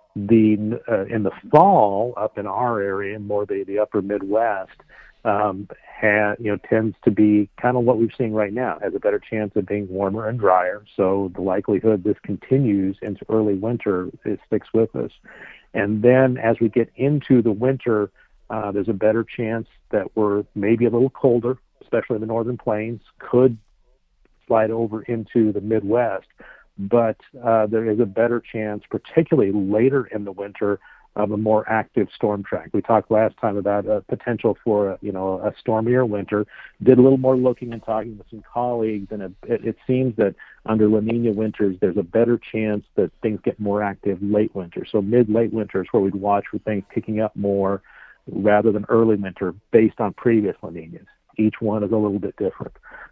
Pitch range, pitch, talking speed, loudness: 105-115 Hz, 110 Hz, 190 wpm, -21 LUFS